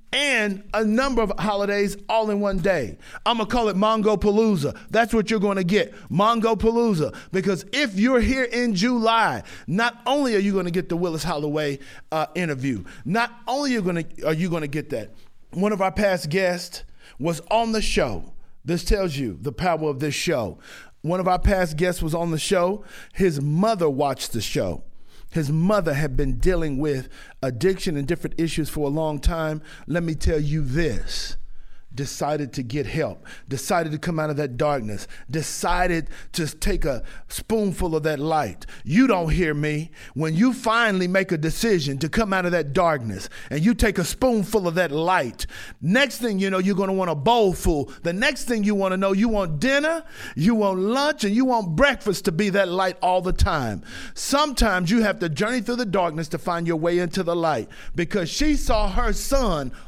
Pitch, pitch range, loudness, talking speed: 185 Hz, 155-220 Hz, -23 LUFS, 200 wpm